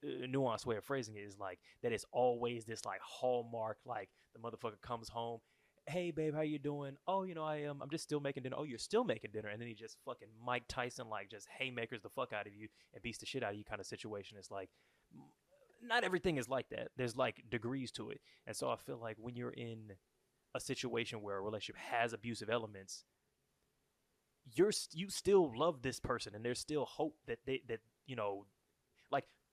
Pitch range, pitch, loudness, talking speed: 110-140 Hz, 120 Hz, -41 LUFS, 225 wpm